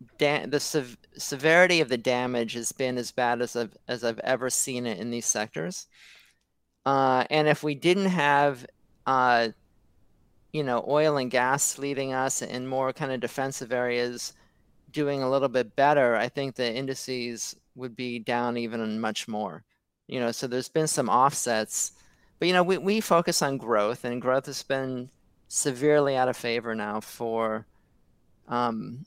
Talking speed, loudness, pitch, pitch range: 170 wpm, -26 LUFS, 125 Hz, 120-140 Hz